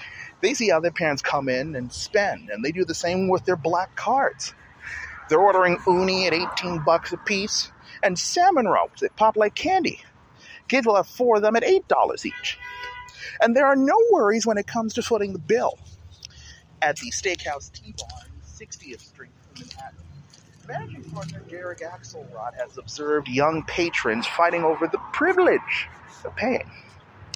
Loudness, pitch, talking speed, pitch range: -22 LUFS, 185 Hz, 165 wpm, 160-265 Hz